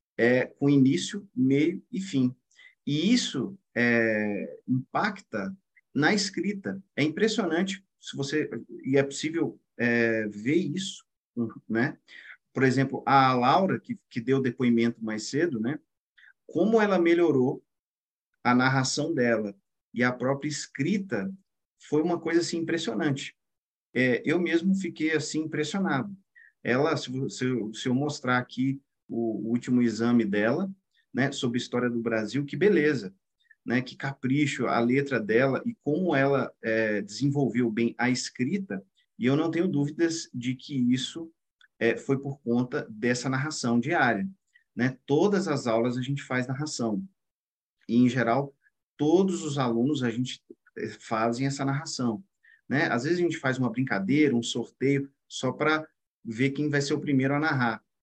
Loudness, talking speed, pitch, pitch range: -27 LUFS, 145 wpm, 135 Hz, 120-165 Hz